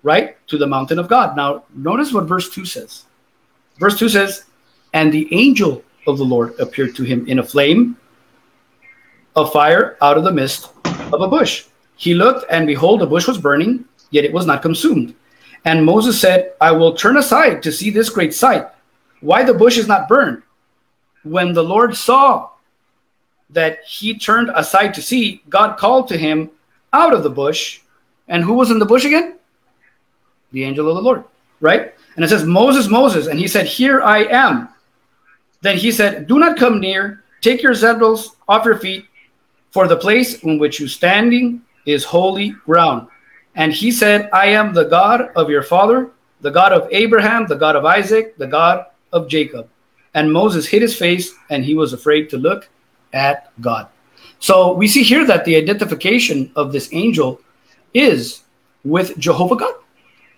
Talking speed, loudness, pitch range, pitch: 180 wpm, -14 LUFS, 155-235 Hz, 190 Hz